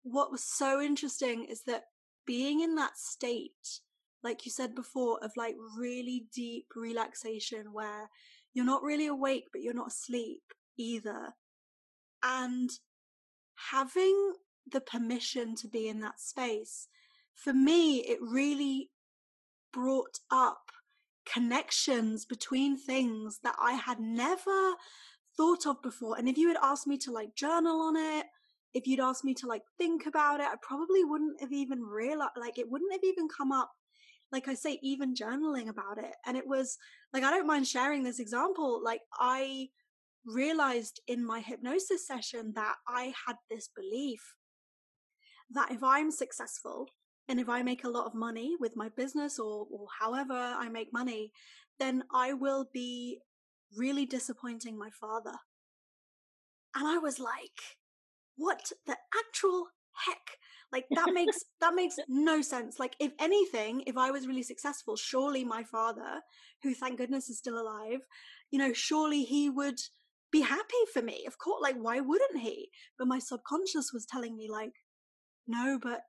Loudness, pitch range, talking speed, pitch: -34 LUFS, 240-295 Hz, 160 wpm, 265 Hz